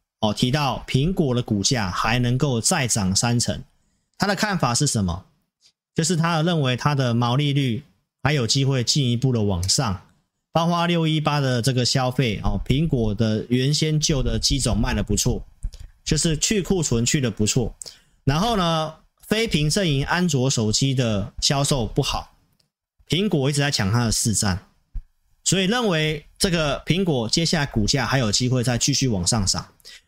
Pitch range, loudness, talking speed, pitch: 115-155 Hz, -21 LUFS, 245 characters per minute, 135 Hz